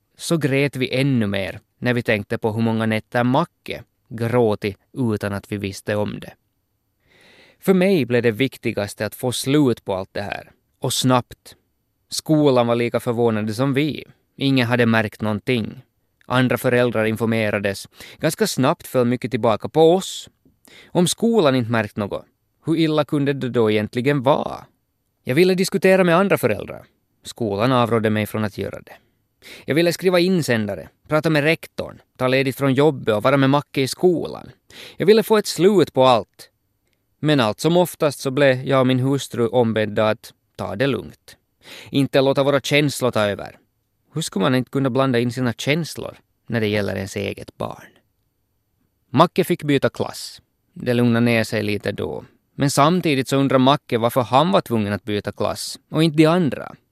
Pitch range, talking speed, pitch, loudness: 110-140 Hz, 175 wpm, 125 Hz, -20 LUFS